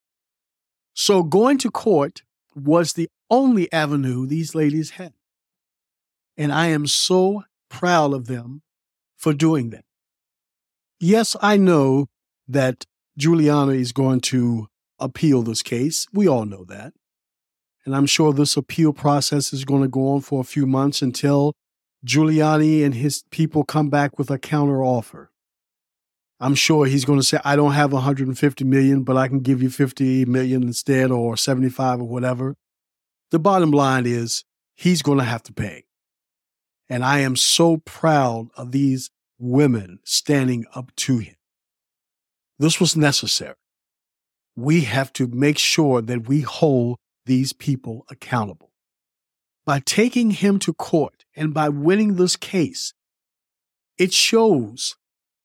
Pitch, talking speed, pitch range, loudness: 140 Hz, 145 wpm, 130-155 Hz, -19 LUFS